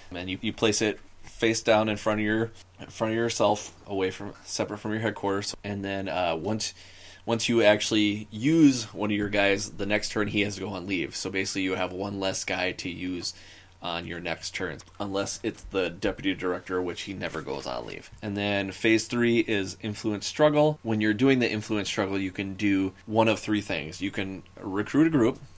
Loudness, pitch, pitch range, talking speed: -27 LUFS, 100 Hz, 95-110 Hz, 215 wpm